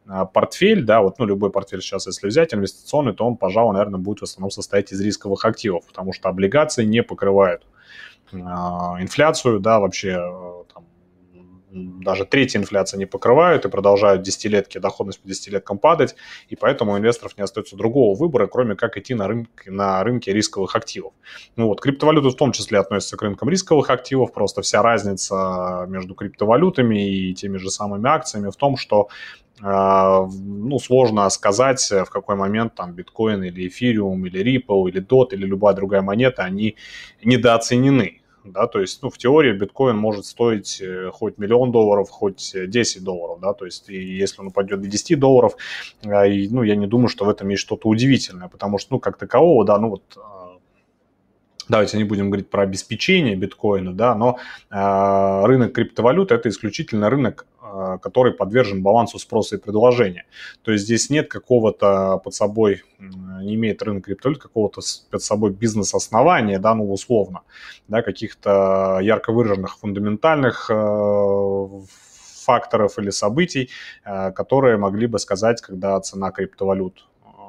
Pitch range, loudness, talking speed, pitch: 95-115 Hz, -19 LUFS, 155 wpm, 100 Hz